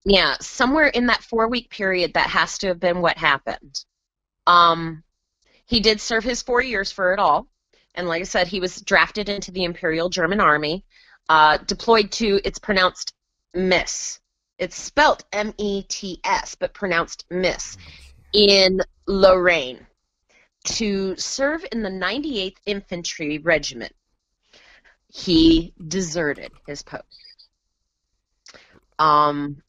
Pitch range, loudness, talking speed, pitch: 165-210 Hz, -20 LUFS, 130 wpm, 185 Hz